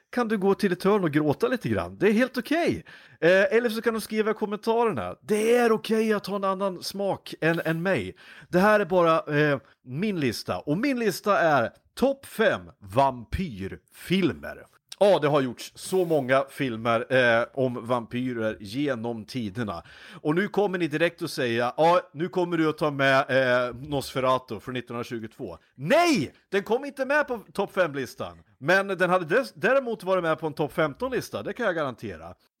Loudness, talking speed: -25 LUFS, 190 wpm